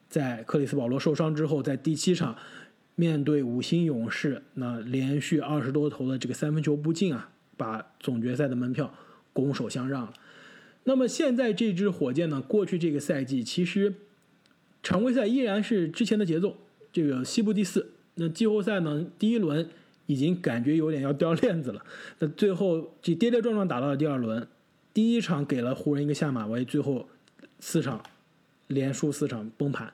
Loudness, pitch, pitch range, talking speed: -28 LUFS, 155 Hz, 135-195 Hz, 275 characters per minute